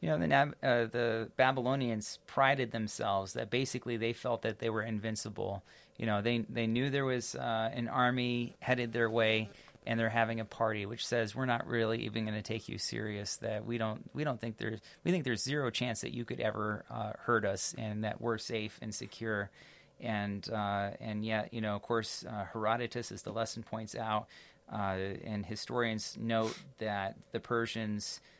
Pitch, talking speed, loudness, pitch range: 115 Hz, 195 wpm, -35 LUFS, 105-120 Hz